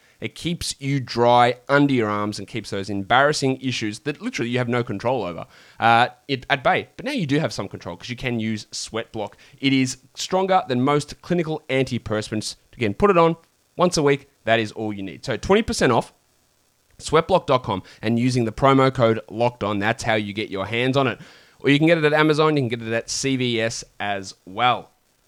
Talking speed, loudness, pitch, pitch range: 210 wpm, -21 LUFS, 125 Hz, 110-140 Hz